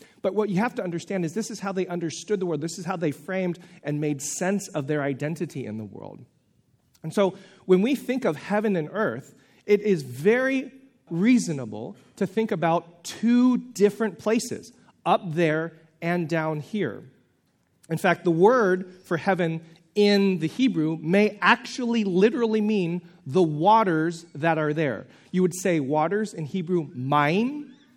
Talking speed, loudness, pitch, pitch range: 165 wpm, -25 LUFS, 180 Hz, 160-210 Hz